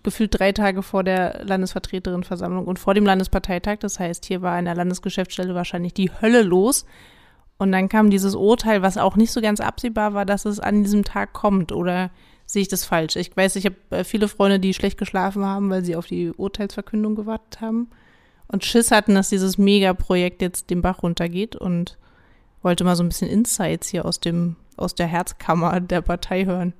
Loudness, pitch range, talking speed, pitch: -21 LUFS, 180-205 Hz, 195 wpm, 190 Hz